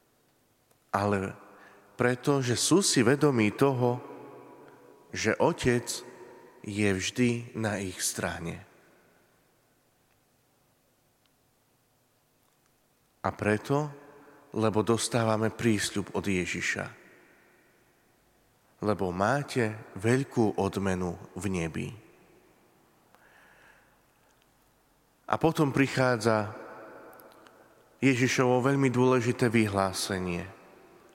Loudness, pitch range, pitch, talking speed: -28 LUFS, 100-125 Hz, 115 Hz, 65 wpm